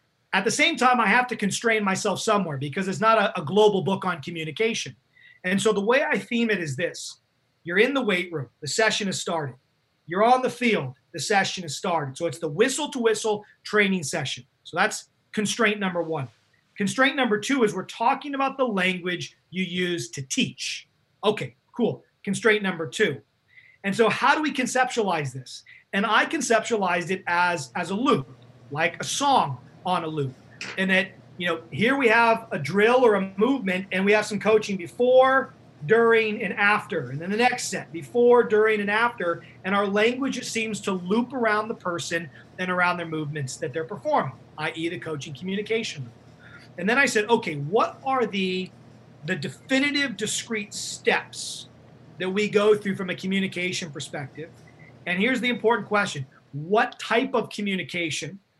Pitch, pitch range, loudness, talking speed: 190 Hz, 160-220 Hz, -24 LUFS, 180 wpm